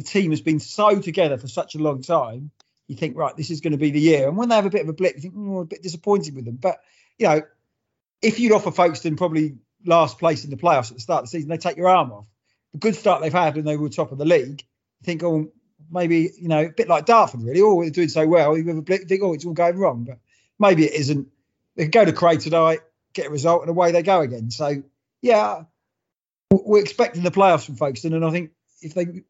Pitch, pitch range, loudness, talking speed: 165 Hz, 150-180 Hz, -20 LUFS, 270 wpm